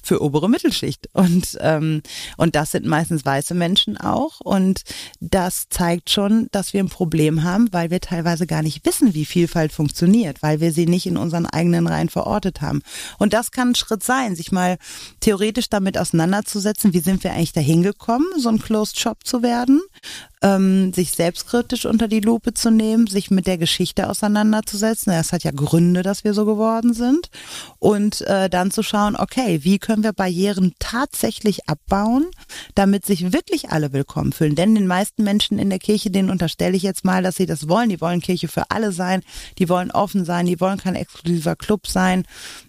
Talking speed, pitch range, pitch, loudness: 190 wpm, 170-215 Hz, 190 Hz, -19 LUFS